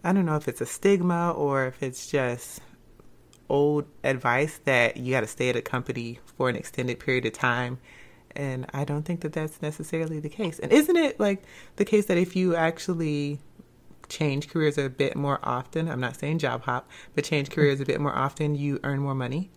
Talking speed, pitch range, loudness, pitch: 205 wpm, 135-165 Hz, -26 LUFS, 145 Hz